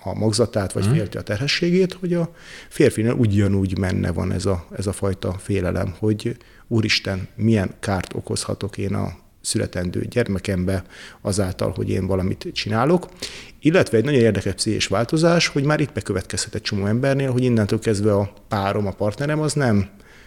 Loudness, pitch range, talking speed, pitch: -21 LUFS, 95-120 Hz, 160 wpm, 105 Hz